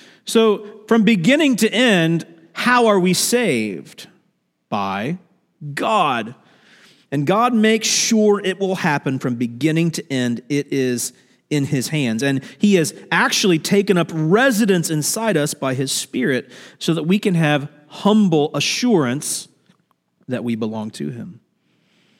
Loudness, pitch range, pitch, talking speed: -18 LUFS, 145-215 Hz, 175 Hz, 140 wpm